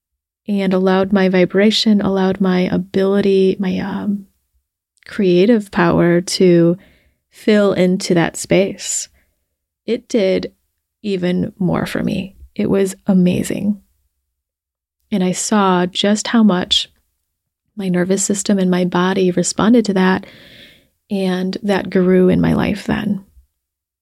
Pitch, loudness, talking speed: 185 Hz, -16 LUFS, 115 wpm